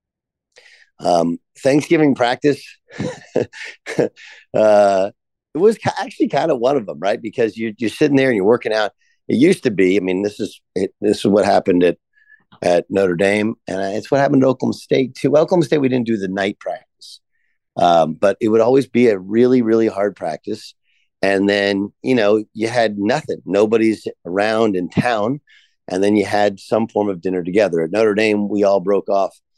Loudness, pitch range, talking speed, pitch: -17 LUFS, 100-125 Hz, 190 wpm, 110 Hz